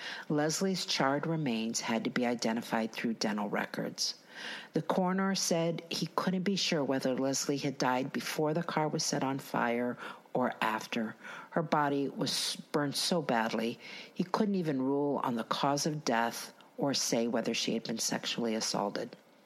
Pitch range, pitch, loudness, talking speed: 130-170 Hz, 145 Hz, -32 LUFS, 165 wpm